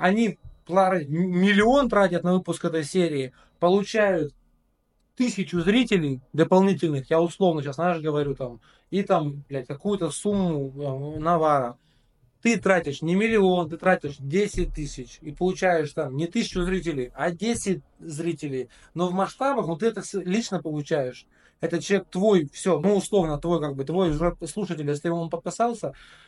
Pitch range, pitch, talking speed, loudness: 150-195 Hz, 175 Hz, 145 wpm, -24 LUFS